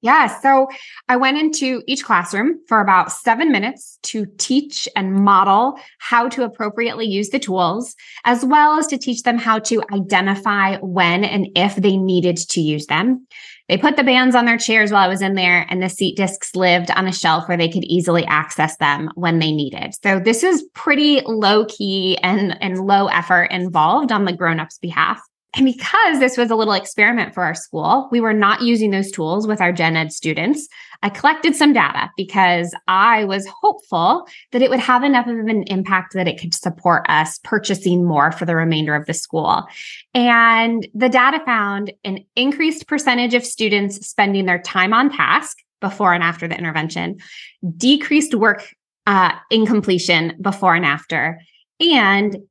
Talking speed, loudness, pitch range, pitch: 180 wpm, -16 LUFS, 180-245 Hz, 200 Hz